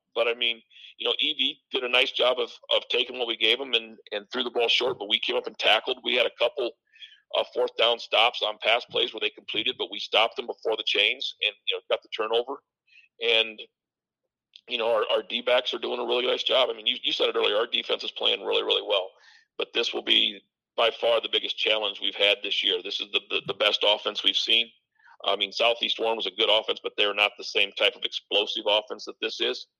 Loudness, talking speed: -24 LUFS, 250 wpm